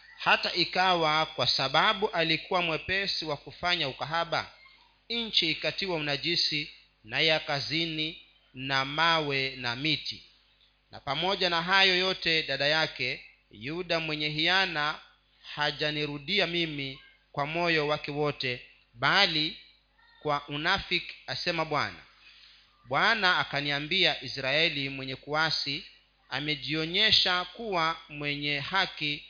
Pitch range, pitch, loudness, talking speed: 140-175 Hz, 155 Hz, -27 LUFS, 100 wpm